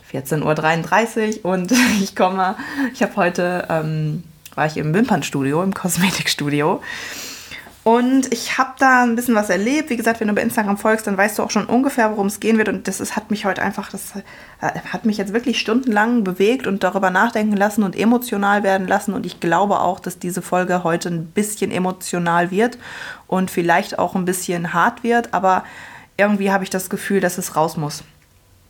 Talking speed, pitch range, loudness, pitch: 190 wpm, 180-220 Hz, -19 LUFS, 195 Hz